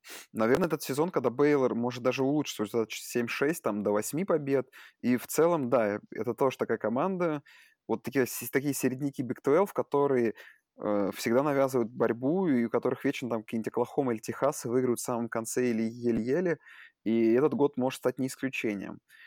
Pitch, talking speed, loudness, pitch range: 125 Hz, 170 wpm, -29 LUFS, 115-140 Hz